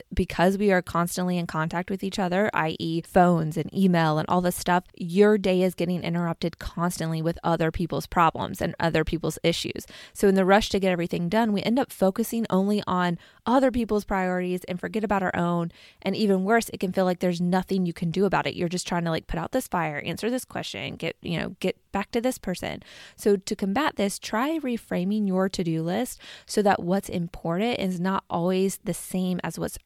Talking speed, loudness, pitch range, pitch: 215 wpm, -25 LUFS, 170-200 Hz, 185 Hz